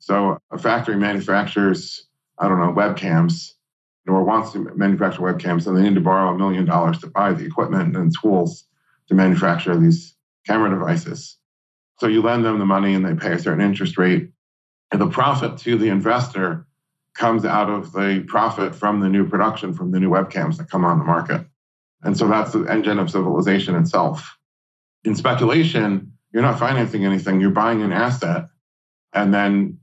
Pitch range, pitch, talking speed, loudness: 95-140 Hz, 105 Hz, 180 wpm, -19 LUFS